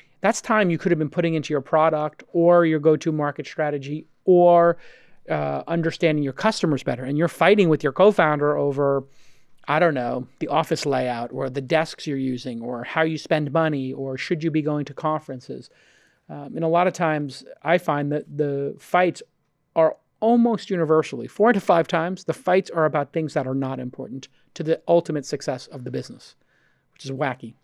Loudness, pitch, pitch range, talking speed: -22 LUFS, 155 Hz, 140-165 Hz, 195 wpm